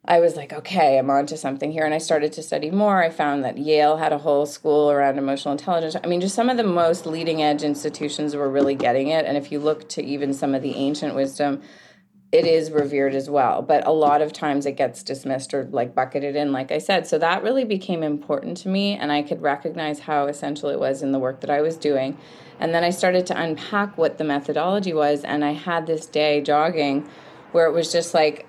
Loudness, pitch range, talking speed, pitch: -22 LUFS, 145-165 Hz, 240 wpm, 150 Hz